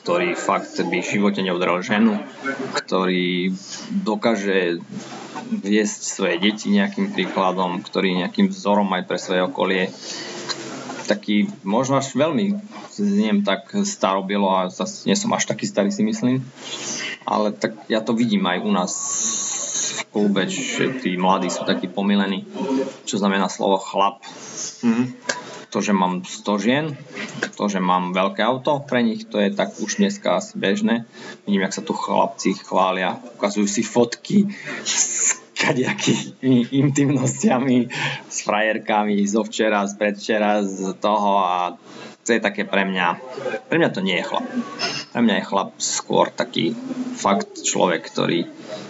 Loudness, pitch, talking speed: -21 LUFS, 105 Hz, 145 wpm